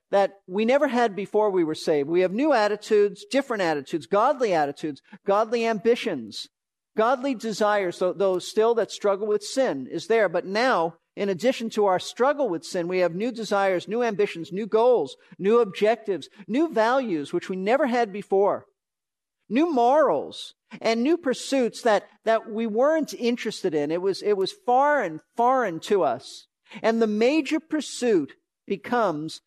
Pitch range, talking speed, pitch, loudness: 195-255 Hz, 160 wpm, 220 Hz, -24 LUFS